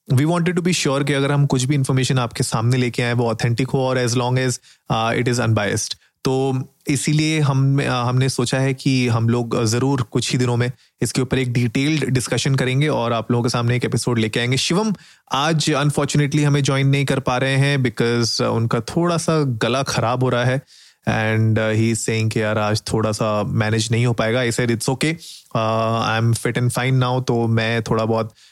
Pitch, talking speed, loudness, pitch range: 125 Hz, 210 wpm, -19 LUFS, 115-135 Hz